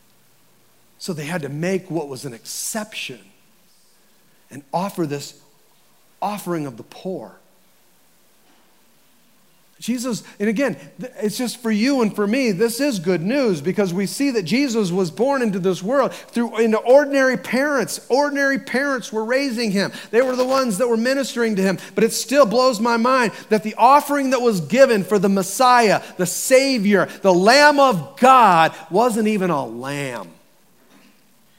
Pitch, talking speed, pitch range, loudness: 220 Hz, 160 wpm, 190-255 Hz, -18 LUFS